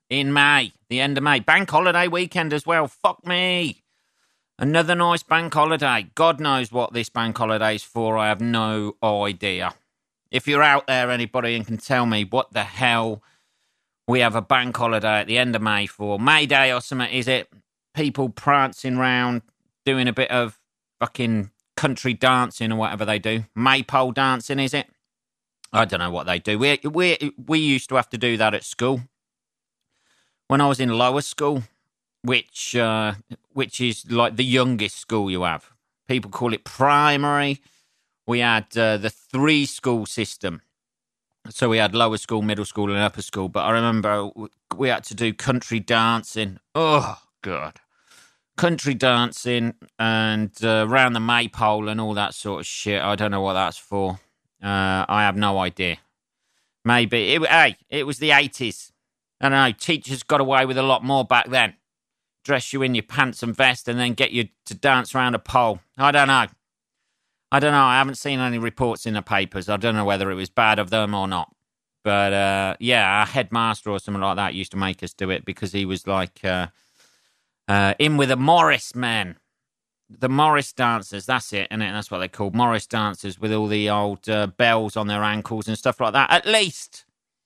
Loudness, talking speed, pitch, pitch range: -21 LUFS, 190 wpm, 115 Hz, 105-135 Hz